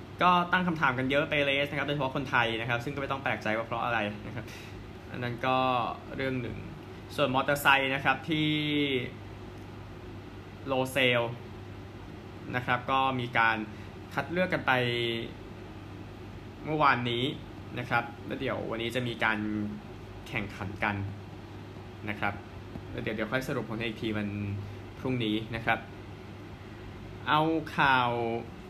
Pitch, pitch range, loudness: 115 Hz, 100-130 Hz, -29 LUFS